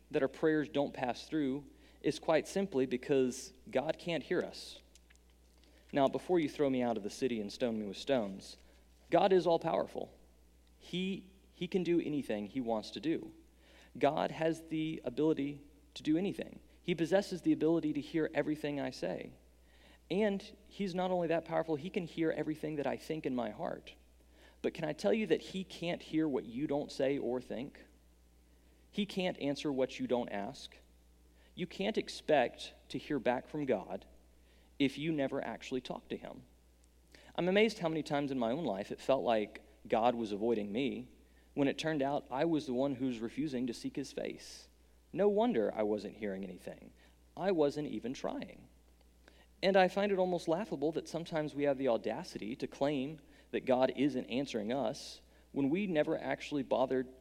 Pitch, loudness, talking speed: 135 Hz, -35 LUFS, 180 wpm